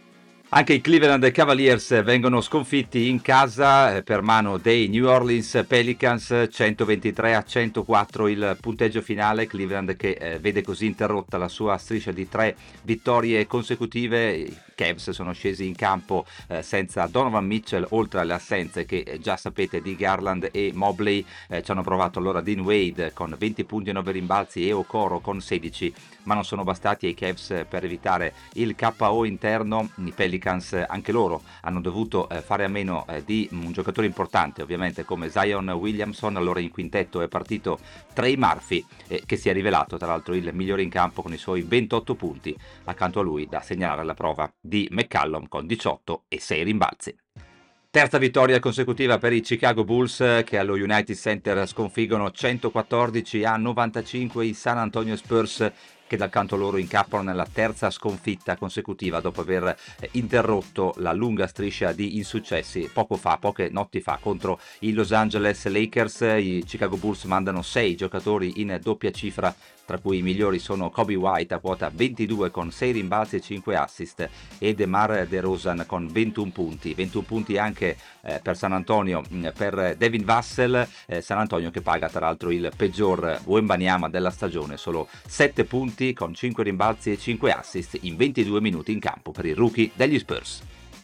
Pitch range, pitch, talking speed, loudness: 95-115 Hz, 105 Hz, 160 wpm, -24 LUFS